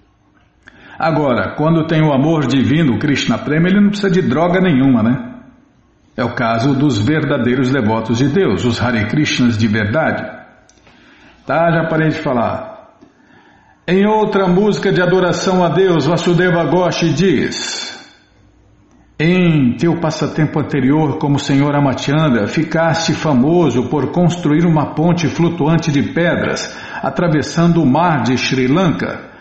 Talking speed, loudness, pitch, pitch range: 135 wpm, -14 LUFS, 155 Hz, 135-170 Hz